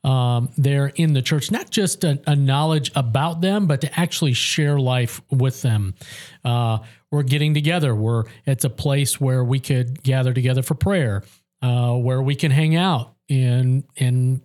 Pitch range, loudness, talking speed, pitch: 125-150 Hz, -20 LUFS, 180 wpm, 135 Hz